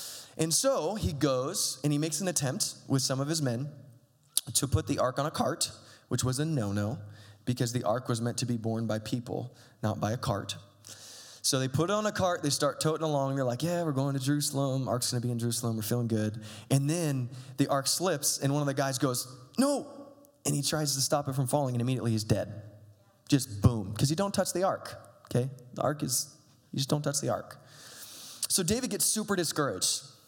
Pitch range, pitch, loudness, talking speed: 120-150 Hz, 135 Hz, -30 LUFS, 225 wpm